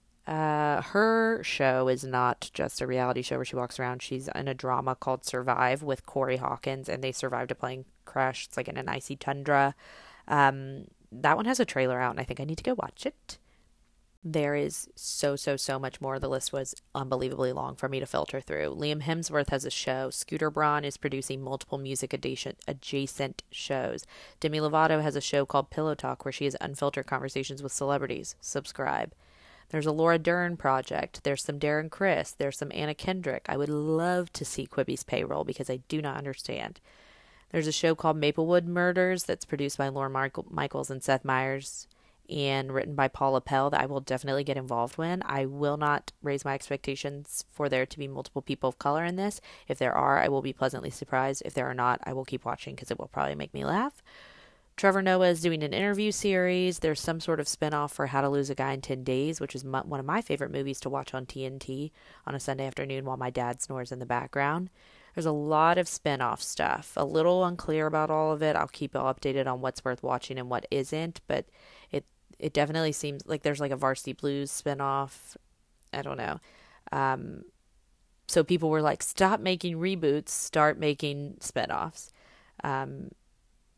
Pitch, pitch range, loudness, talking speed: 140 Hz, 130-155 Hz, -30 LUFS, 205 wpm